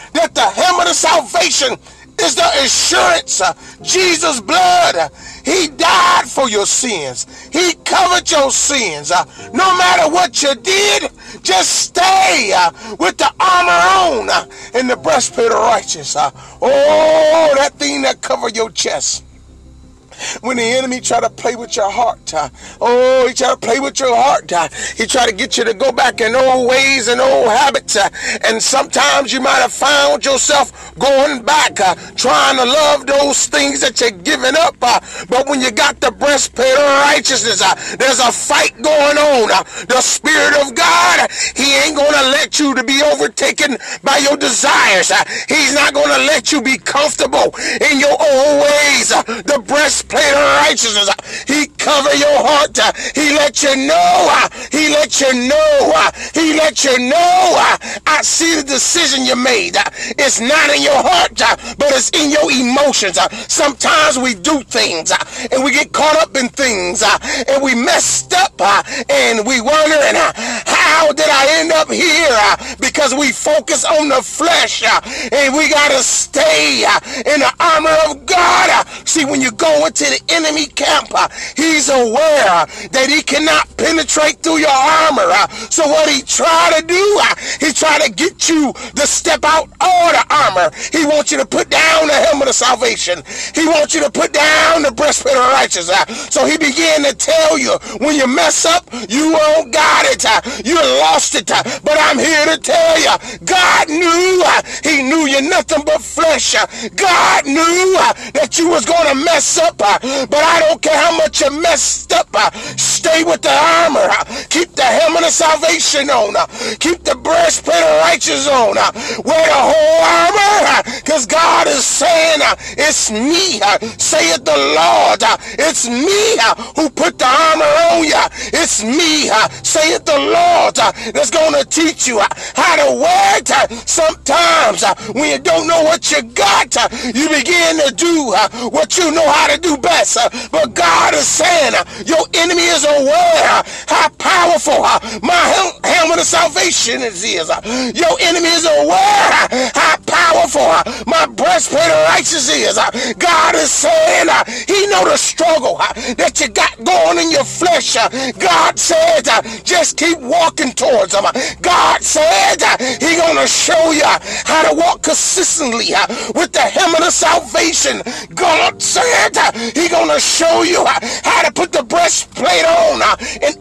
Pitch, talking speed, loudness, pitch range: 305 Hz, 170 wpm, -11 LUFS, 275-330 Hz